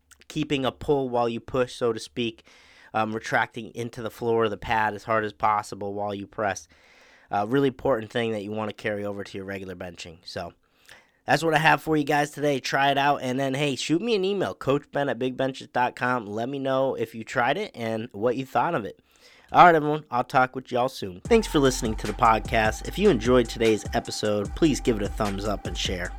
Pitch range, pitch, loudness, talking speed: 110-135 Hz, 120 Hz, -25 LUFS, 230 wpm